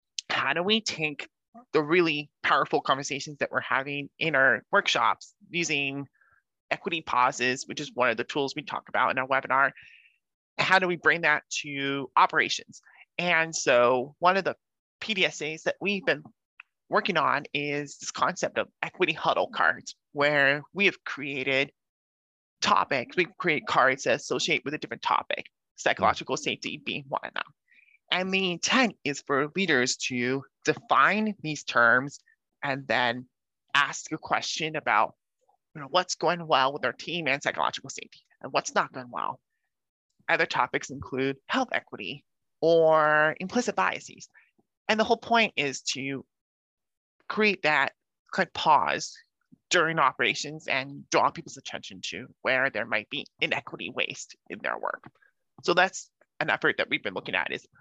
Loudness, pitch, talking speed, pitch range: -26 LUFS, 150 Hz, 160 wpm, 135-180 Hz